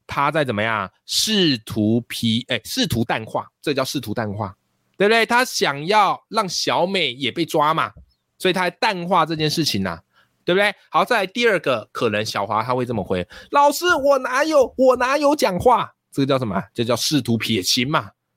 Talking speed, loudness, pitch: 275 characters per minute, -20 LUFS, 150 Hz